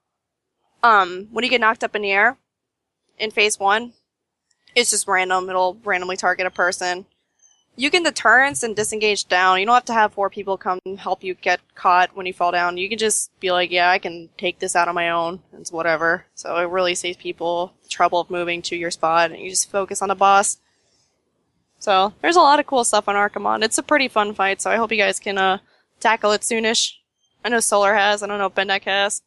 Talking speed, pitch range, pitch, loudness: 230 wpm, 180-215 Hz, 195 Hz, -19 LUFS